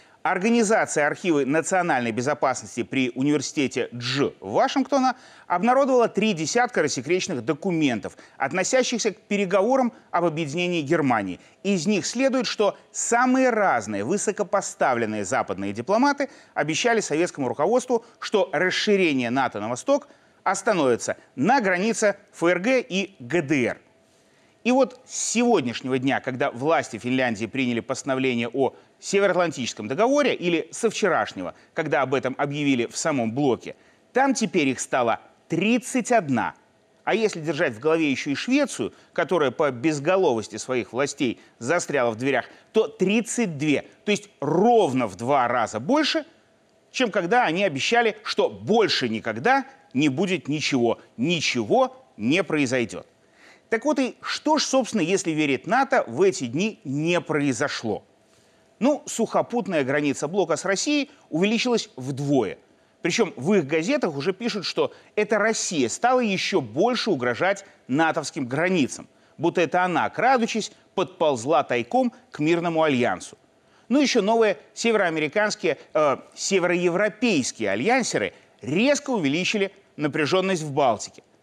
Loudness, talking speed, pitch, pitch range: -23 LUFS, 120 wpm, 190 Hz, 145-235 Hz